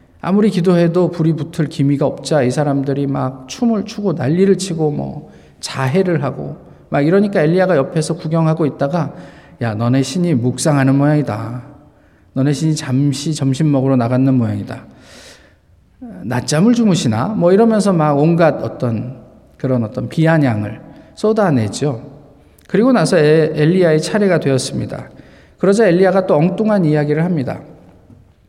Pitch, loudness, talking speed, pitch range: 150 Hz, -15 LUFS, 320 characters per minute, 135-175 Hz